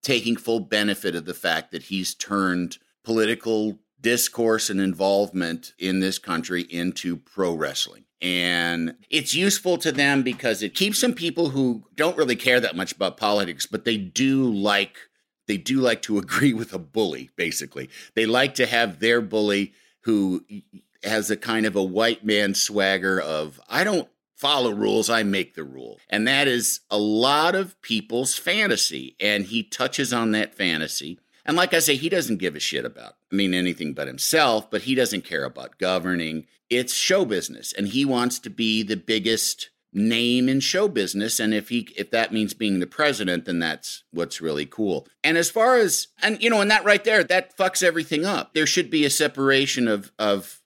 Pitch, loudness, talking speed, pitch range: 110 Hz, -22 LUFS, 190 wpm, 100-135 Hz